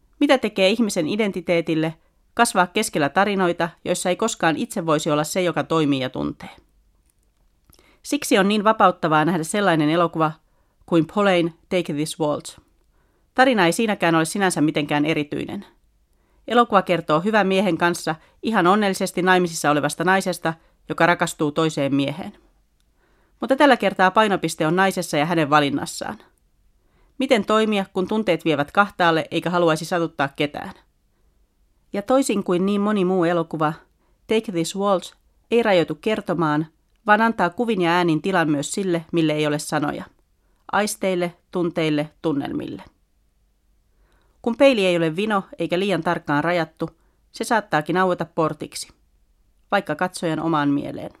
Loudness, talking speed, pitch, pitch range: -21 LUFS, 135 wpm, 175 Hz, 155-195 Hz